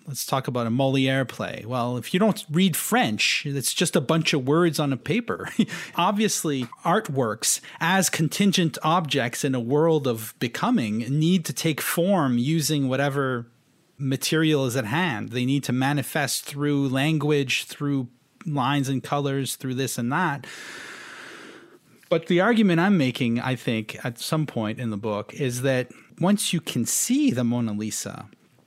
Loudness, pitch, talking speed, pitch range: -24 LUFS, 140 Hz, 160 wpm, 125-165 Hz